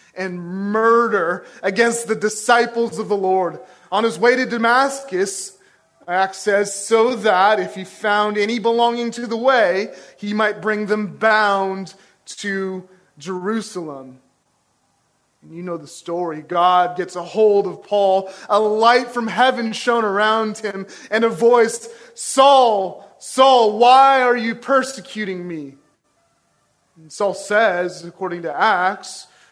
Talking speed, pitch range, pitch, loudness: 135 wpm, 185-235 Hz, 210 Hz, -18 LUFS